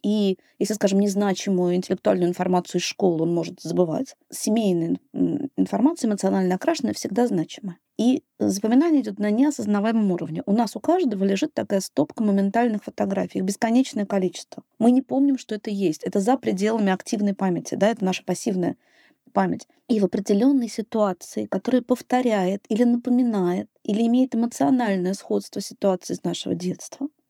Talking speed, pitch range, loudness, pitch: 145 wpm, 190-245 Hz, -23 LUFS, 210 Hz